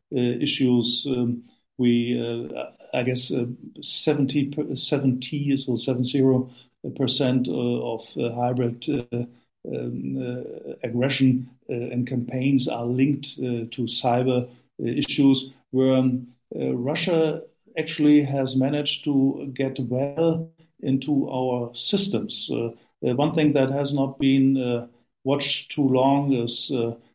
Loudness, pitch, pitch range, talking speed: -24 LUFS, 130 Hz, 120-140 Hz, 125 wpm